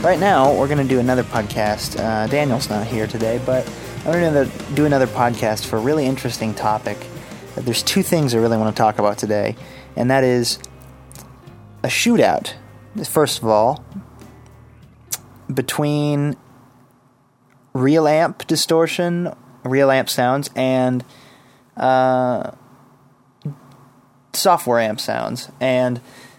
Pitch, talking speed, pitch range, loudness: 125 Hz, 125 wpm, 115-140 Hz, -19 LUFS